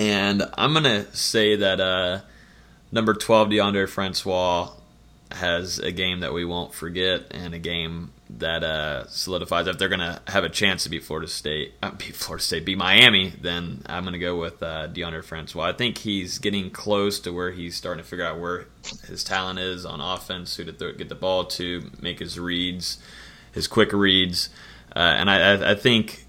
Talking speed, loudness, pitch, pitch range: 190 wpm, -23 LUFS, 95 Hz, 90-100 Hz